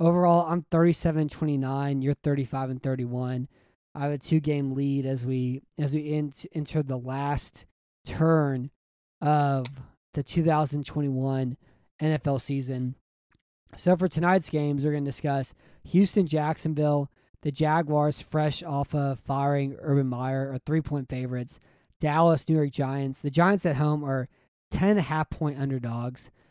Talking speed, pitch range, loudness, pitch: 140 wpm, 130-155 Hz, -27 LUFS, 145 Hz